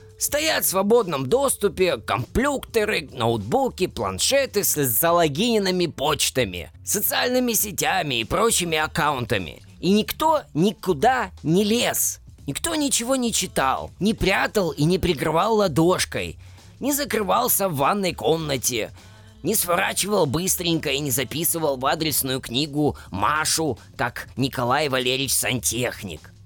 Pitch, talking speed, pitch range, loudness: 165 Hz, 110 wpm, 130-205 Hz, -22 LUFS